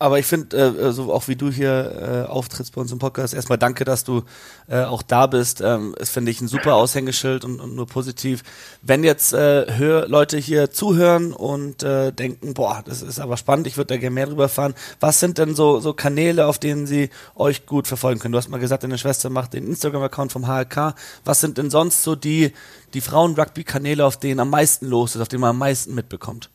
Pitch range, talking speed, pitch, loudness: 125-145 Hz, 225 wpm, 135 Hz, -19 LUFS